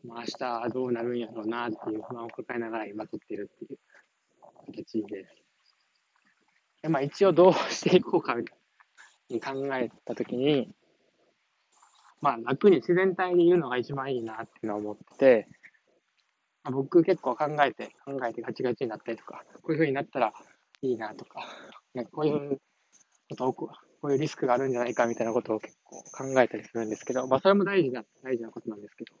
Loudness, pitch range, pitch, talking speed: -28 LUFS, 115-150 Hz, 130 Hz, 375 characters per minute